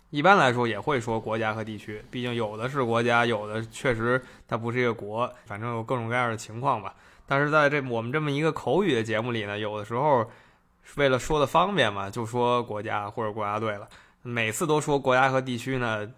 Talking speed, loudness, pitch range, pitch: 325 characters per minute, -26 LUFS, 110-130 Hz, 120 Hz